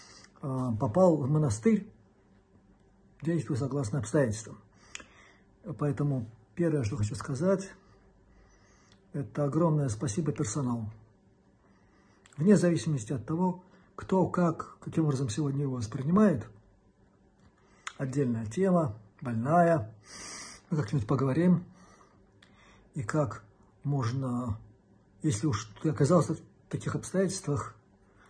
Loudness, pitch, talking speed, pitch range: -30 LUFS, 140 Hz, 90 wpm, 105-160 Hz